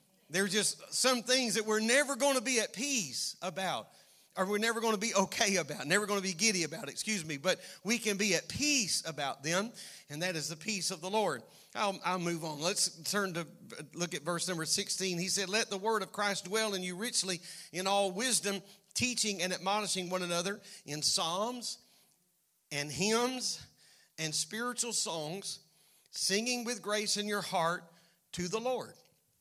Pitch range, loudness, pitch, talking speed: 180-220 Hz, -33 LUFS, 195 Hz, 190 wpm